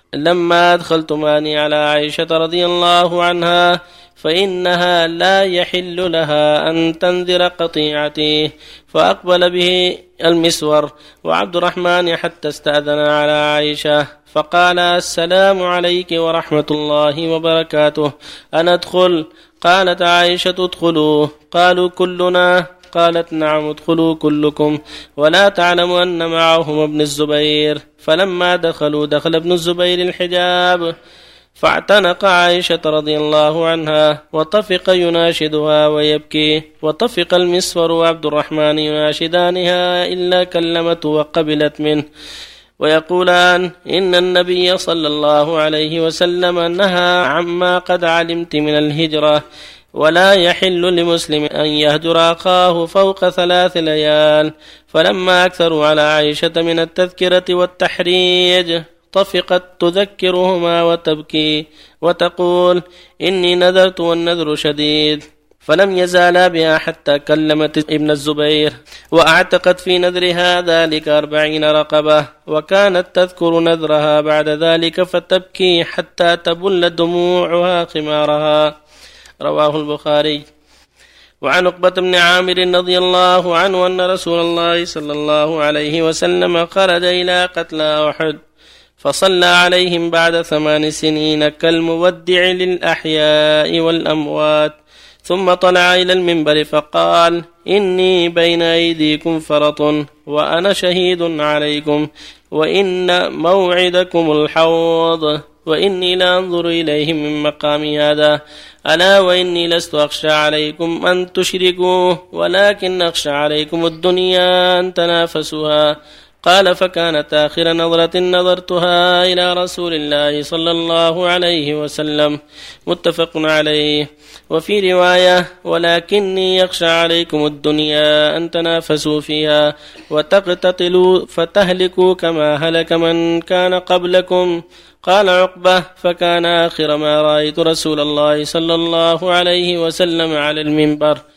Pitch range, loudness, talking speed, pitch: 150-180 Hz, -13 LUFS, 100 wpm, 165 Hz